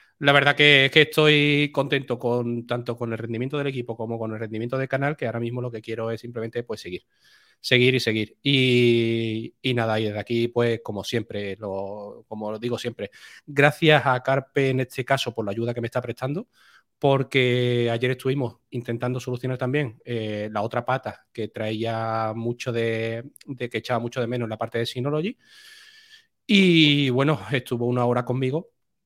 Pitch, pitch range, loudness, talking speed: 120 Hz, 115-135 Hz, -23 LUFS, 190 wpm